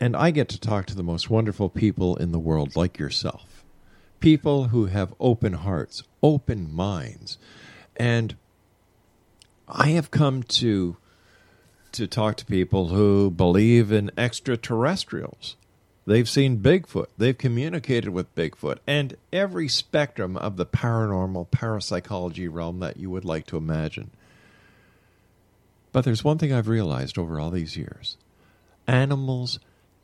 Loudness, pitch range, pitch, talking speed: -24 LUFS, 90-125 Hz, 105 Hz, 135 wpm